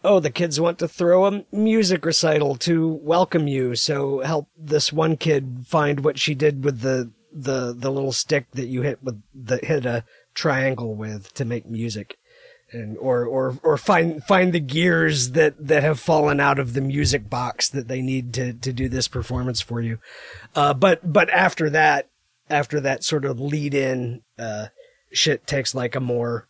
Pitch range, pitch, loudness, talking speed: 125-160 Hz, 140 Hz, -21 LUFS, 190 wpm